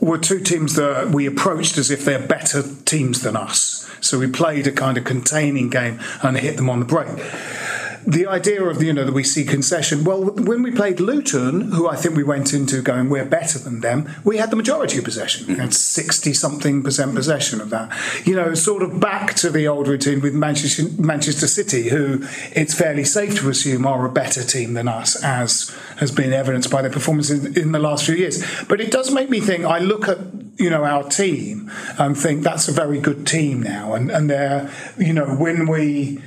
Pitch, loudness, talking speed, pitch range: 150 Hz, -18 LUFS, 215 wpm, 140-170 Hz